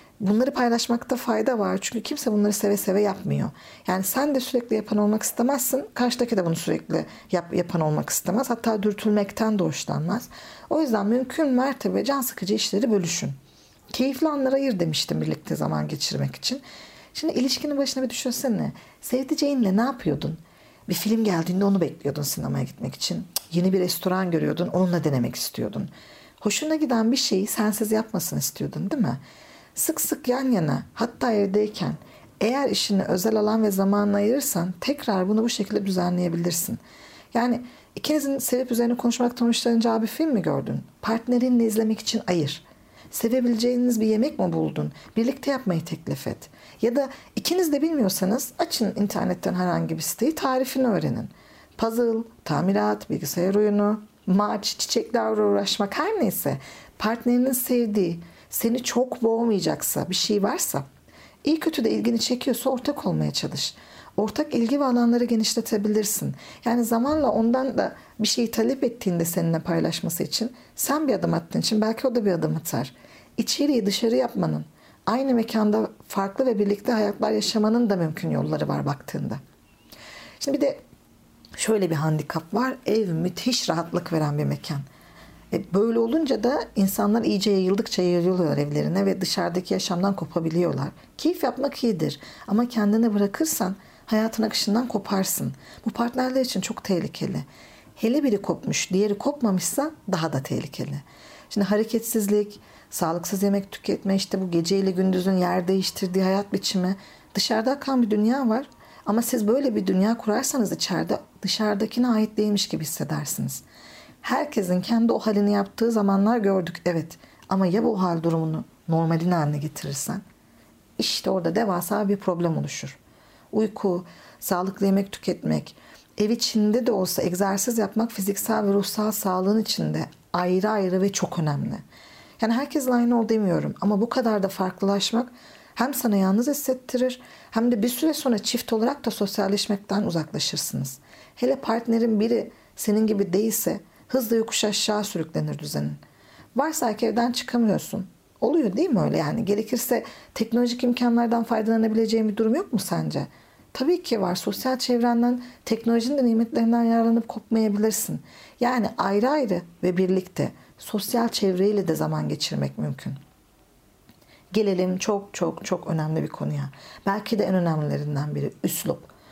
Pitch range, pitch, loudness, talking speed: 185-240 Hz, 215 Hz, -24 LUFS, 145 wpm